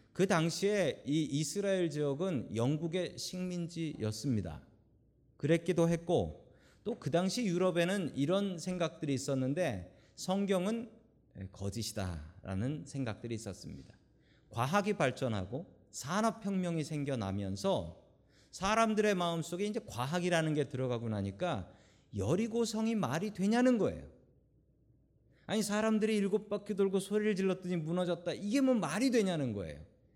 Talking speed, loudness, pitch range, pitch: 300 characters per minute, -34 LUFS, 125-200 Hz, 170 Hz